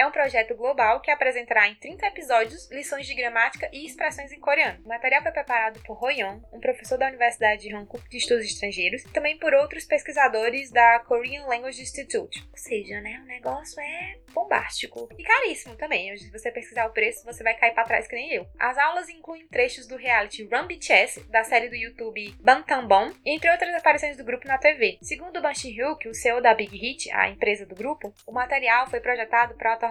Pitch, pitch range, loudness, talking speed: 255 Hz, 230-300 Hz, -24 LUFS, 205 wpm